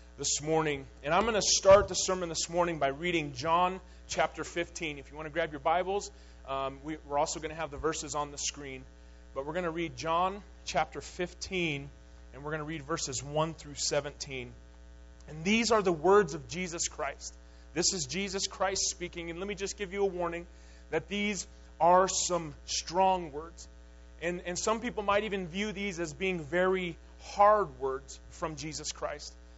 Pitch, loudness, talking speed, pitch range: 160 Hz, -31 LUFS, 195 wpm, 135-185 Hz